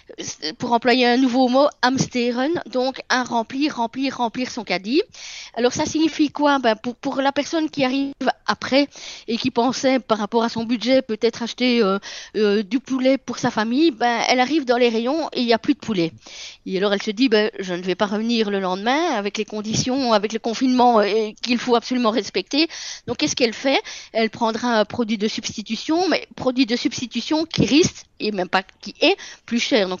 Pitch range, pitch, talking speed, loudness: 220-270 Hz, 245 Hz, 205 wpm, -20 LUFS